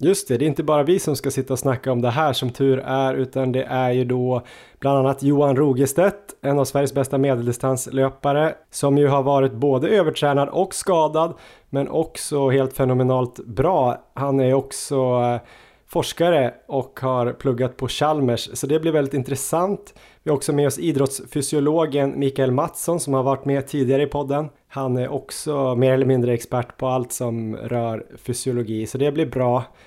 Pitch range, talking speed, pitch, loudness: 130-145 Hz, 180 wpm, 135 Hz, -21 LUFS